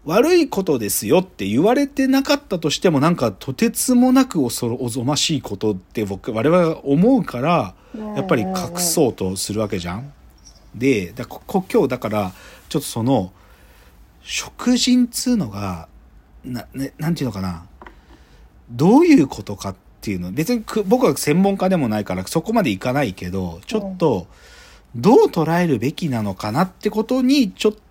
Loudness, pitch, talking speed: -19 LUFS, 150 Hz, 335 characters per minute